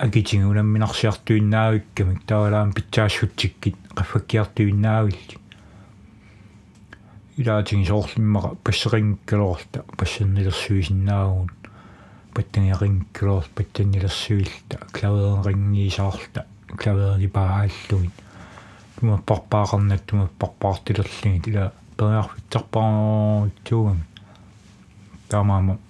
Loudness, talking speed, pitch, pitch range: -22 LUFS, 60 wpm, 105 Hz, 100-110 Hz